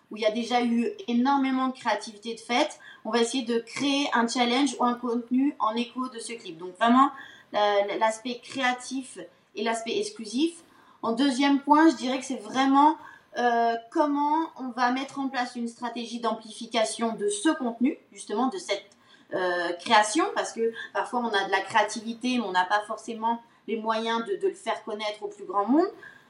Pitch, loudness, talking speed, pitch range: 235 Hz, -26 LUFS, 185 wpm, 220-270 Hz